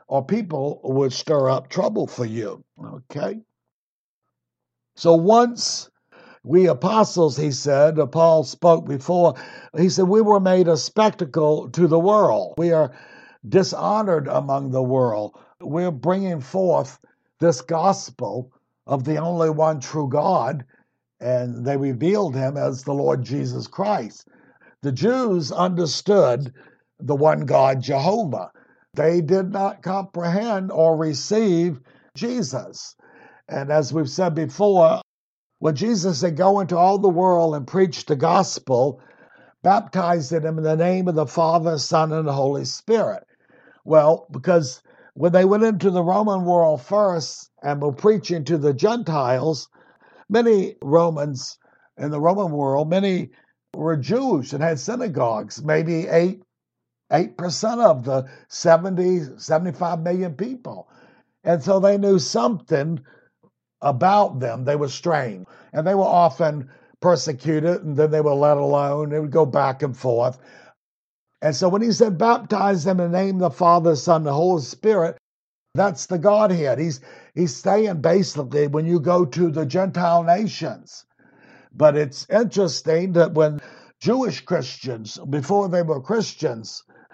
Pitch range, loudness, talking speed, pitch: 145-190 Hz, -20 LUFS, 140 wpm, 165 Hz